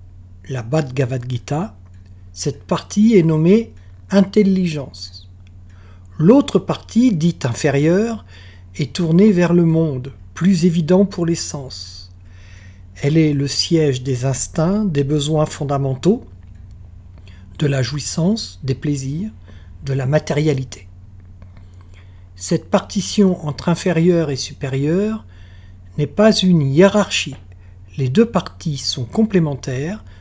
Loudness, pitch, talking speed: -17 LUFS, 140 Hz, 105 wpm